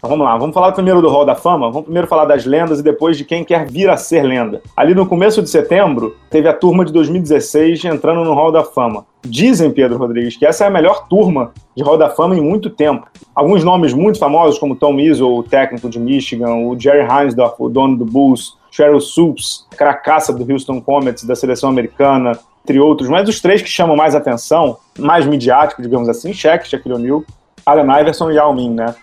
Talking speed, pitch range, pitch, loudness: 215 wpm, 130-165 Hz, 150 Hz, -12 LUFS